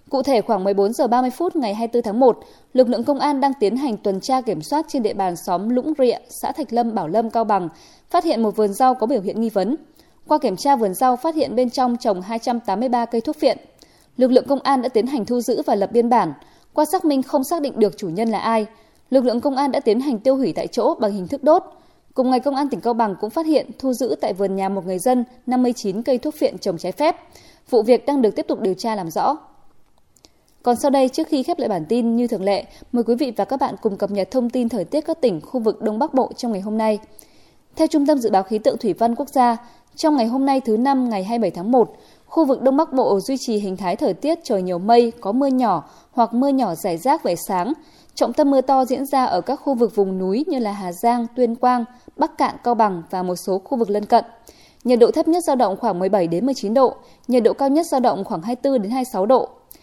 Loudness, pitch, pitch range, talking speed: -20 LUFS, 245 Hz, 215-275 Hz, 265 wpm